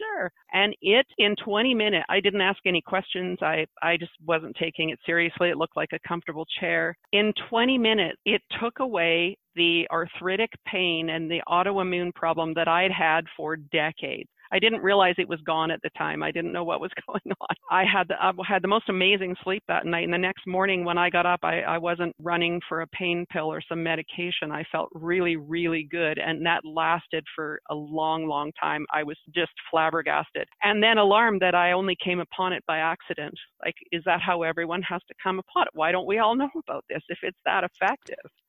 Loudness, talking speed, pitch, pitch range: -25 LUFS, 215 wpm, 175 Hz, 165-190 Hz